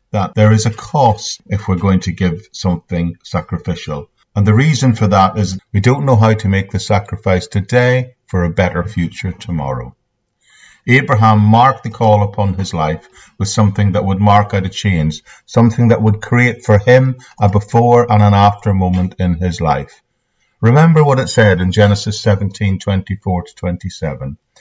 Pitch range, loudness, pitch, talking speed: 90-110 Hz, -14 LUFS, 100 Hz, 175 wpm